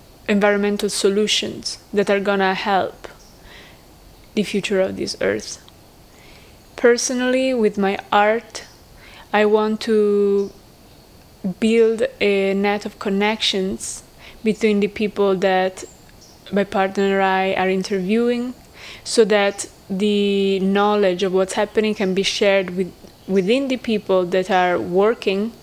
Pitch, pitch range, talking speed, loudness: 200 Hz, 195-215 Hz, 115 wpm, -19 LUFS